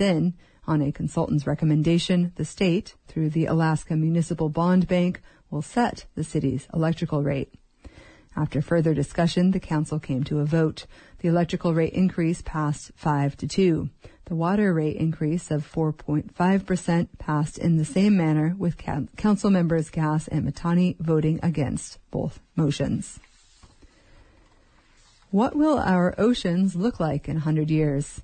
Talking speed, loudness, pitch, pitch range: 140 wpm, -24 LUFS, 165 Hz, 155-180 Hz